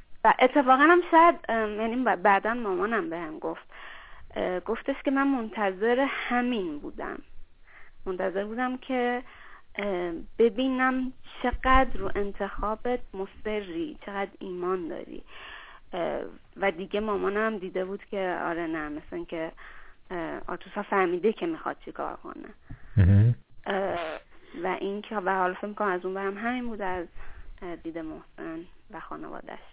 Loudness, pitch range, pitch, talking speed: -28 LUFS, 190-250 Hz, 205 Hz, 120 wpm